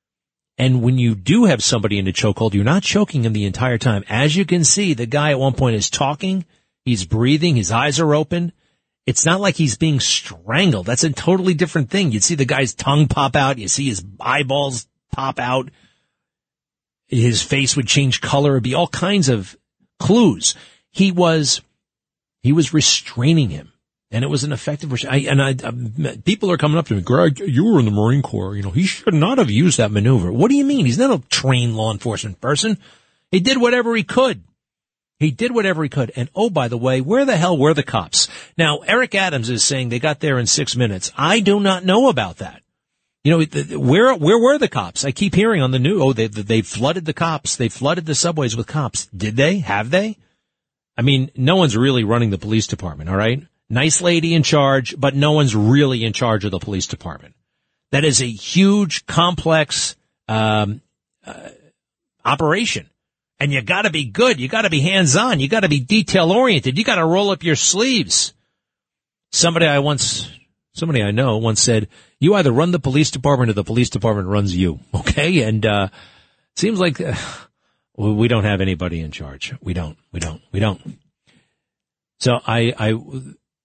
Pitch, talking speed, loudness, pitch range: 135 Hz, 200 wpm, -17 LUFS, 115-165 Hz